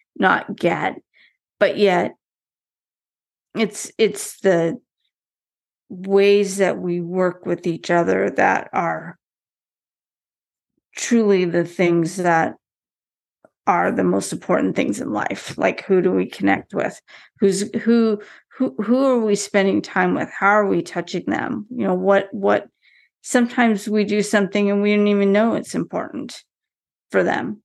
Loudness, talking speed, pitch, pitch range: -19 LUFS, 140 wpm, 200 Hz, 180-215 Hz